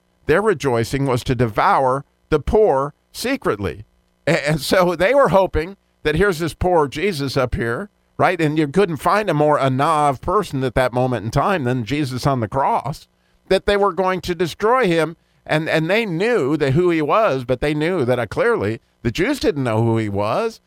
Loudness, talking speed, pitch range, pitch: -19 LUFS, 190 wpm, 130-185 Hz, 150 Hz